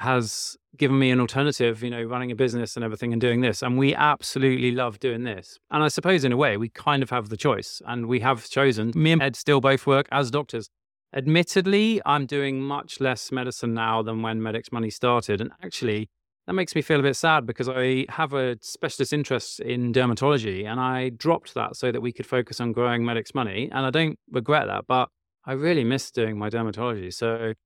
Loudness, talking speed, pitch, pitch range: -24 LUFS, 215 wpm, 125 Hz, 115-140 Hz